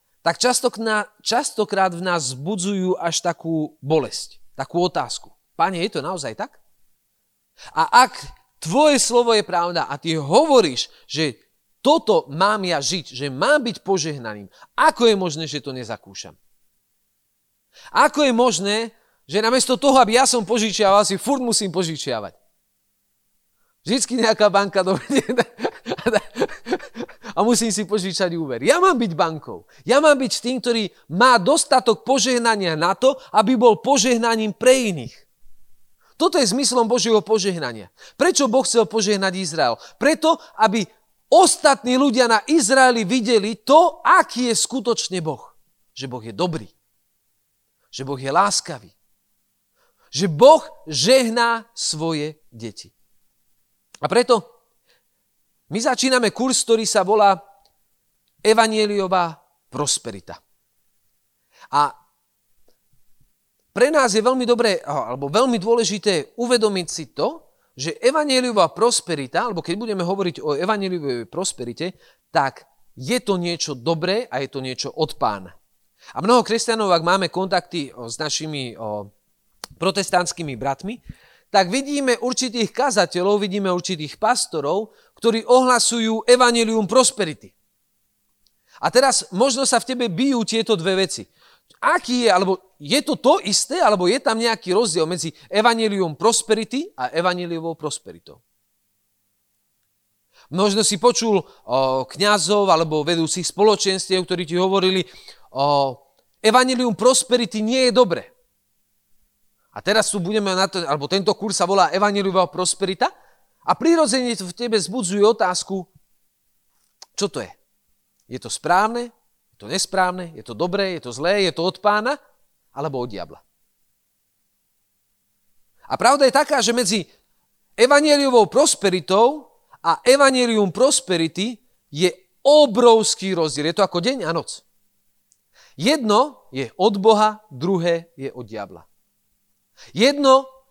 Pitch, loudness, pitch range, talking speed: 200 Hz, -19 LUFS, 160-240 Hz, 125 wpm